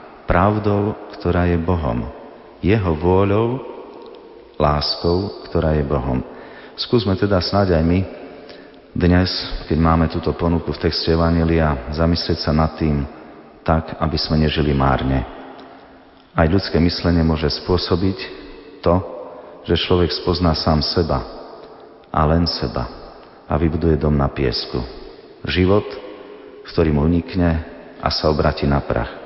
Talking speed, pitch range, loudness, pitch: 125 wpm, 75-90 Hz, -19 LUFS, 85 Hz